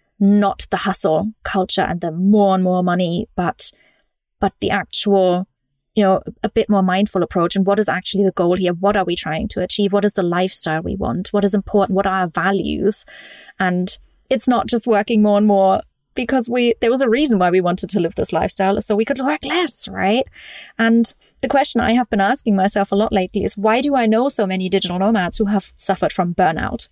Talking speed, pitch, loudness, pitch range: 220 wpm, 200 Hz, -17 LUFS, 185-220 Hz